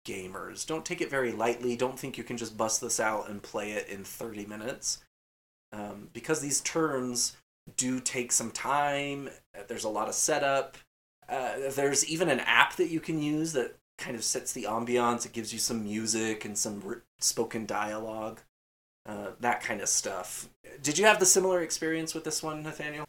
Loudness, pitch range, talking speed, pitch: -30 LUFS, 110-155 Hz, 190 wpm, 125 Hz